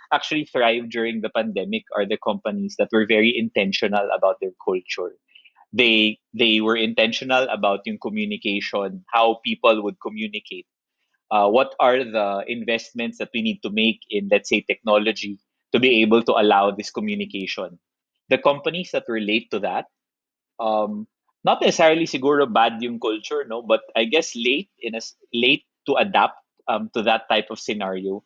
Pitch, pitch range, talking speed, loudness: 115 Hz, 110-165 Hz, 160 wpm, -21 LUFS